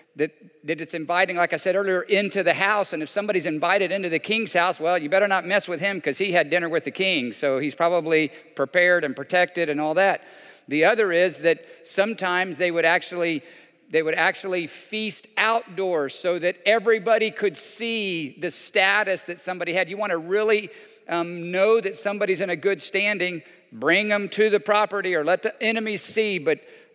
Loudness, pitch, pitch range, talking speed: -22 LUFS, 185 Hz, 170-210 Hz, 195 wpm